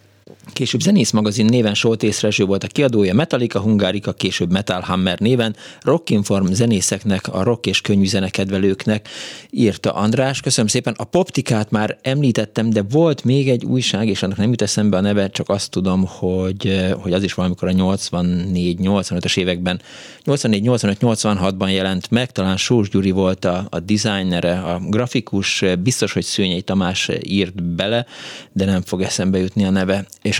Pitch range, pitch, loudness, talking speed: 95-110 Hz, 100 Hz, -18 LUFS, 150 wpm